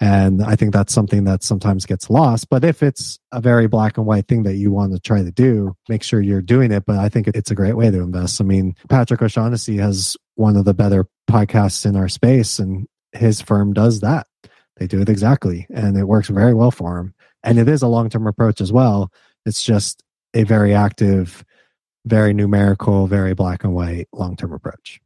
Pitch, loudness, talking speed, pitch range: 105 Hz, -16 LUFS, 220 wpm, 100-115 Hz